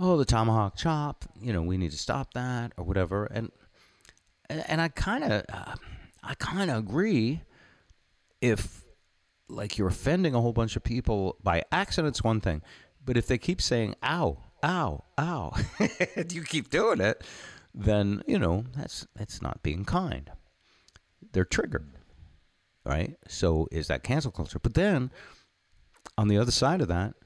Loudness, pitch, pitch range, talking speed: -29 LUFS, 110 Hz, 90-135 Hz, 165 wpm